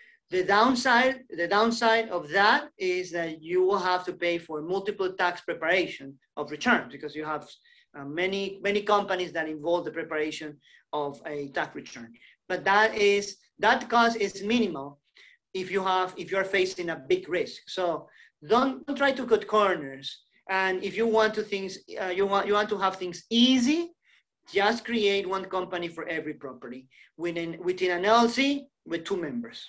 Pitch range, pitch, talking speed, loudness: 170-225 Hz, 195 Hz, 170 wpm, -27 LUFS